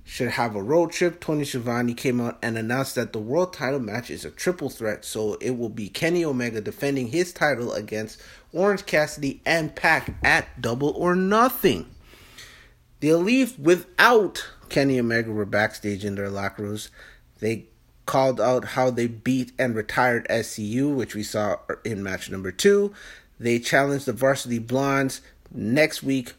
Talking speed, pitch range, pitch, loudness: 160 wpm, 110-150 Hz, 125 Hz, -24 LUFS